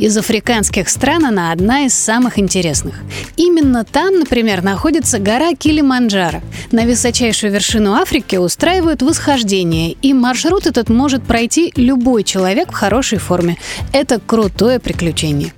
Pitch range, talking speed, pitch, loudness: 195-275 Hz, 125 wpm, 235 Hz, -13 LUFS